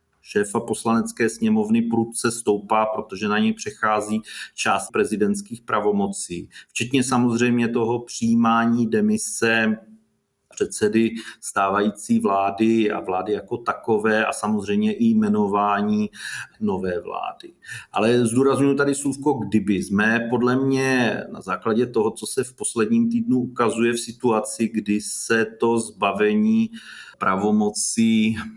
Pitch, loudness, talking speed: 115 Hz, -22 LUFS, 115 wpm